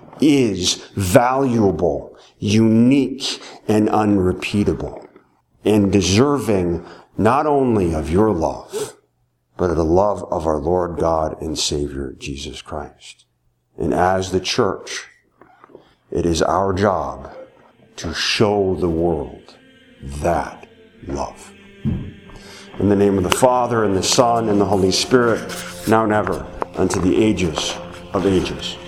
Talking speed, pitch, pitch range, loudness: 125 wpm, 95 Hz, 85-110 Hz, -18 LUFS